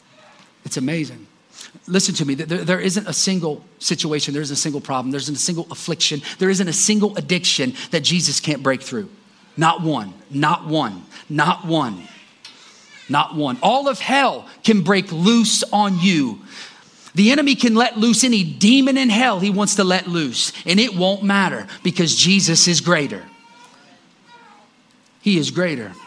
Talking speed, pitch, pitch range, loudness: 165 wpm, 185 Hz, 160-220 Hz, -18 LUFS